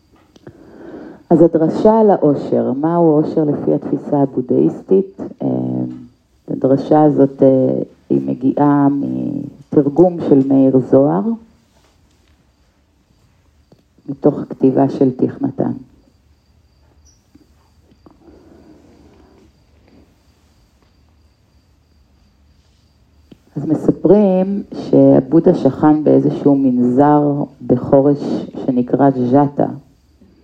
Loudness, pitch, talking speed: -14 LUFS, 135 Hz, 60 wpm